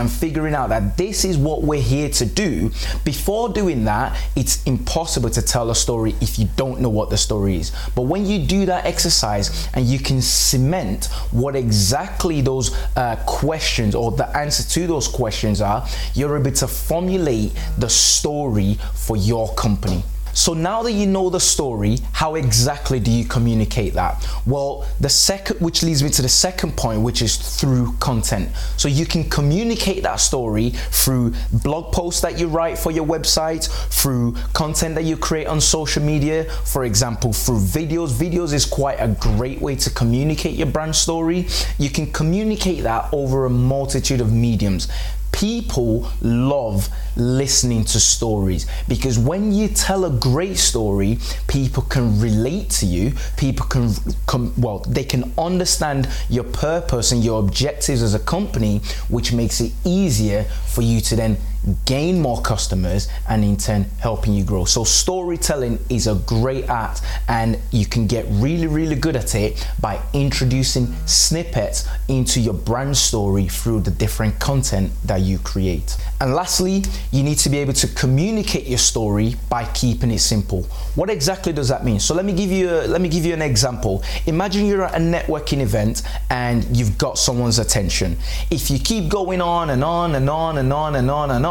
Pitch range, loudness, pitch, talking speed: 110-160 Hz, -19 LUFS, 130 Hz, 175 wpm